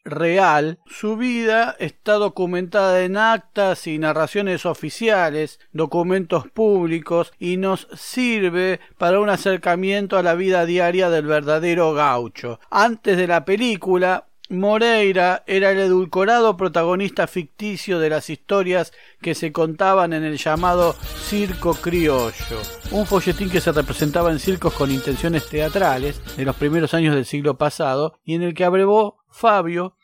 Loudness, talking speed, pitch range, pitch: -19 LUFS, 140 wpm, 155-195 Hz, 180 Hz